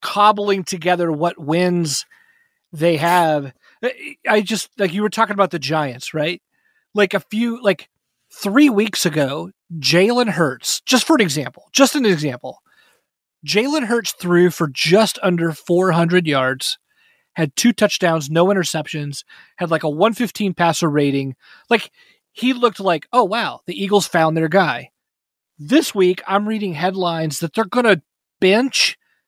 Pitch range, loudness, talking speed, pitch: 160-220 Hz, -18 LUFS, 150 wpm, 185 Hz